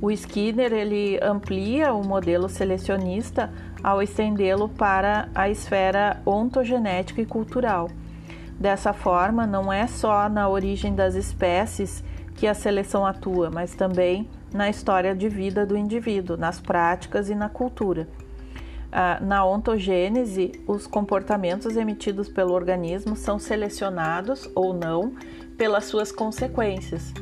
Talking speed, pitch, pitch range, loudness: 120 wpm, 195 Hz, 180-210 Hz, -24 LUFS